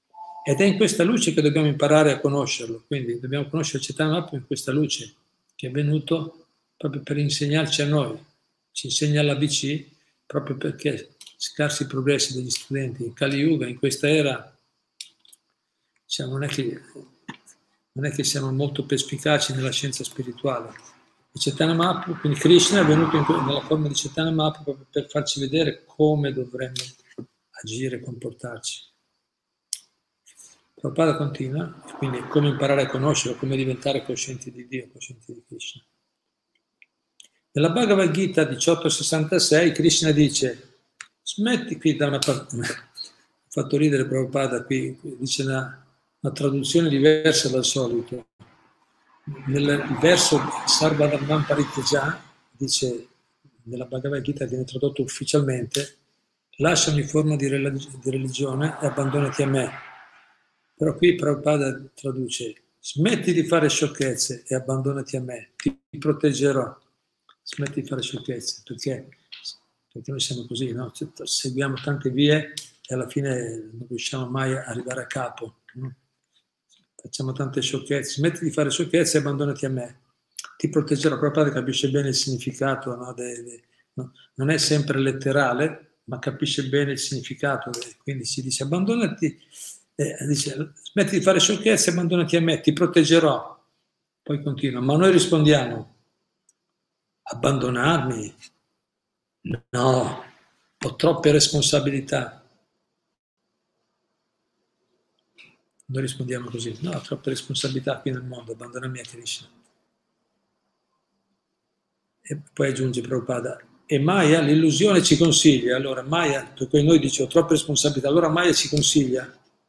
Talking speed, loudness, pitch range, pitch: 130 wpm, -23 LUFS, 130-155 Hz, 140 Hz